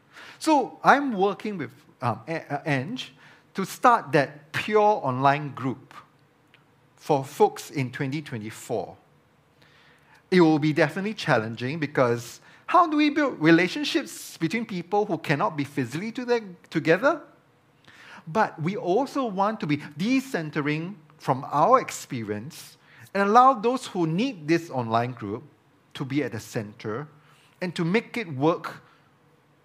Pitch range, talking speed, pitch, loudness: 145-205 Hz, 130 wpm, 155 Hz, -25 LUFS